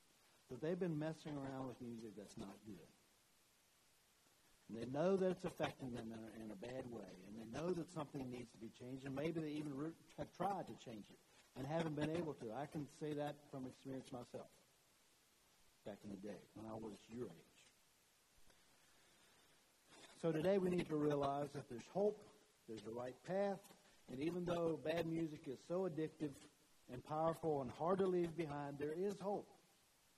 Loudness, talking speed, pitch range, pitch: -45 LUFS, 185 wpm, 120-165 Hz, 145 Hz